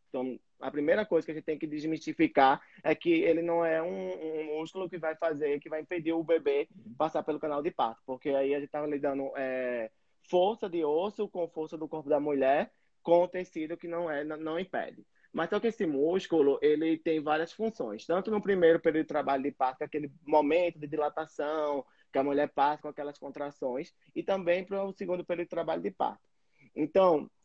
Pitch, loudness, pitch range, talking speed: 155 Hz, -31 LUFS, 145-175 Hz, 215 wpm